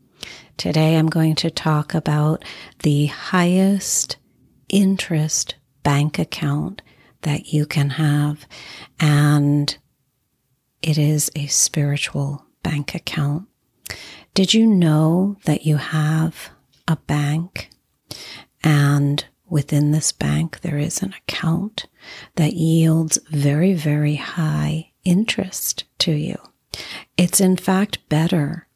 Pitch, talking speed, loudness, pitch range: 155 Hz, 105 wpm, -19 LUFS, 145-170 Hz